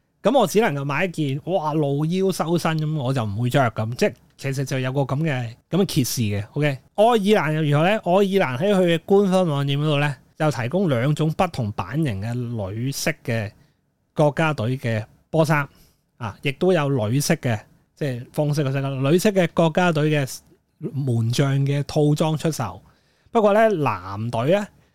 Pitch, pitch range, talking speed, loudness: 150 Hz, 135-170 Hz, 260 characters per minute, -21 LUFS